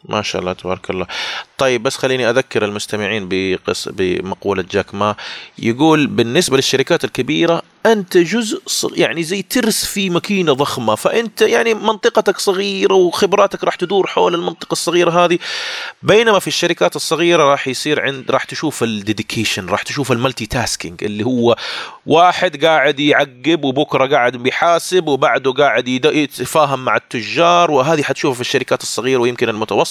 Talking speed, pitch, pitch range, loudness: 145 wpm, 150 Hz, 125-180 Hz, -15 LUFS